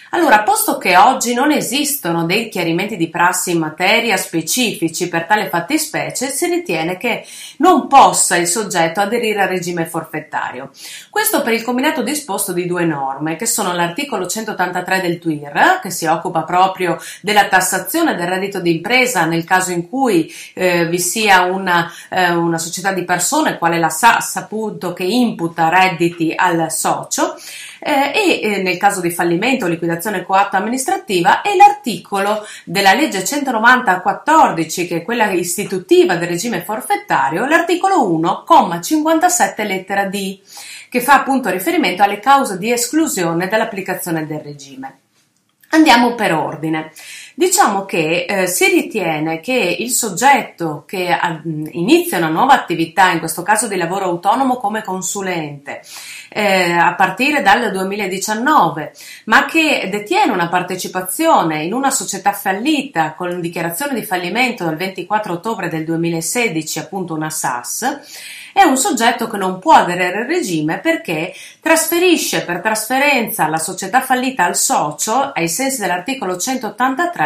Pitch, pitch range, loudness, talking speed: 195 Hz, 170-255 Hz, -15 LUFS, 140 wpm